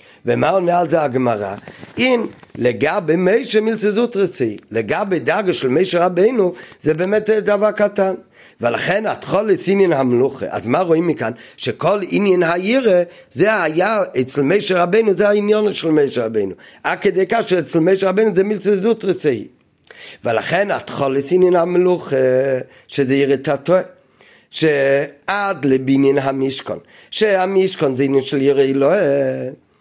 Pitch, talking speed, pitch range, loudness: 175 Hz, 135 wpm, 140-200 Hz, -17 LUFS